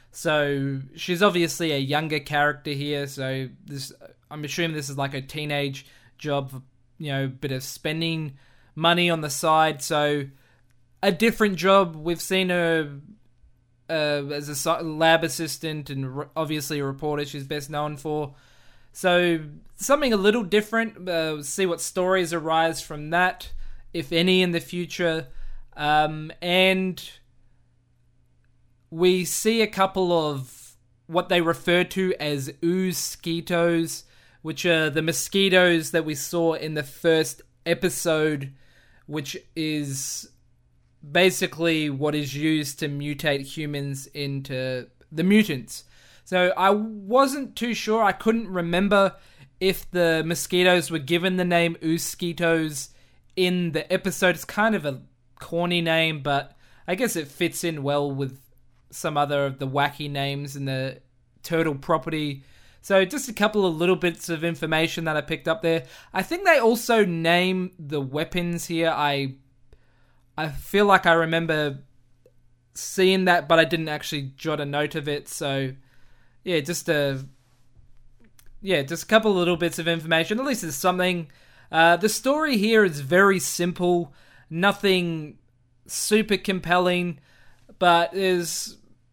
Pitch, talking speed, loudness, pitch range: 160 Hz, 140 wpm, -23 LUFS, 140-175 Hz